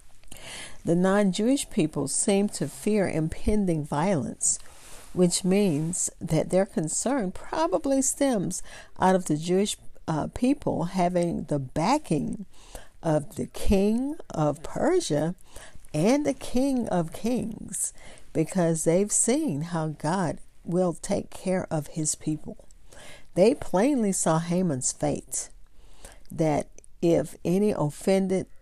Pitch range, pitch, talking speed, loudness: 160-210 Hz, 180 Hz, 115 wpm, -26 LUFS